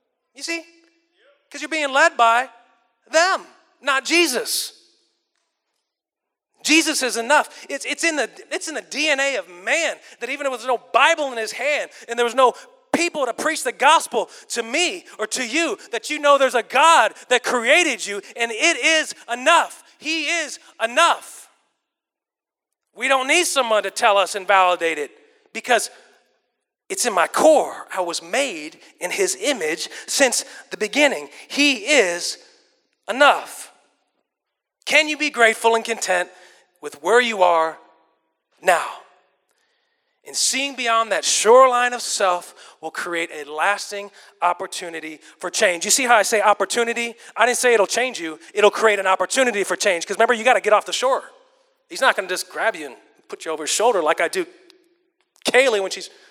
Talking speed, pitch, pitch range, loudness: 170 wpm, 260 Hz, 215-330 Hz, -19 LUFS